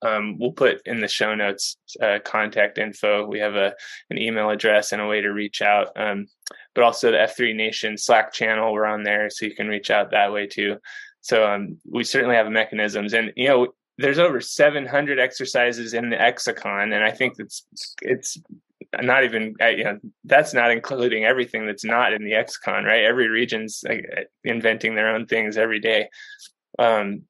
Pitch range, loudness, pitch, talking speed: 105-120 Hz, -21 LUFS, 110 Hz, 190 wpm